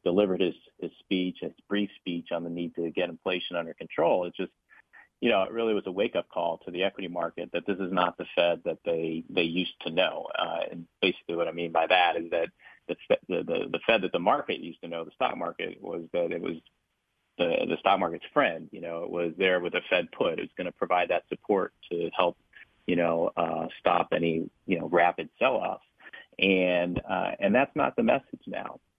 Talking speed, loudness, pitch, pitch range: 230 wpm, -28 LUFS, 85 Hz, 85-90 Hz